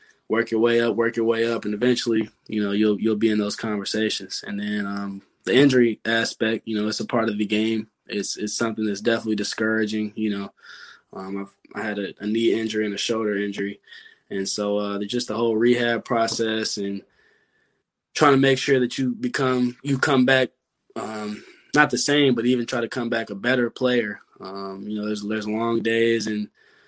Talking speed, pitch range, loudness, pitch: 205 wpm, 105-120 Hz, -23 LUFS, 110 Hz